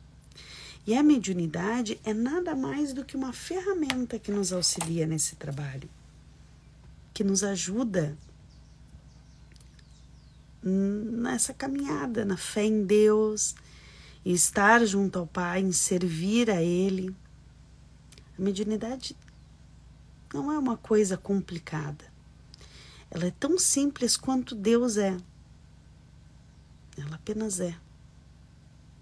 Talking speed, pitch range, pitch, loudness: 105 wpm, 180-240 Hz, 205 Hz, -27 LUFS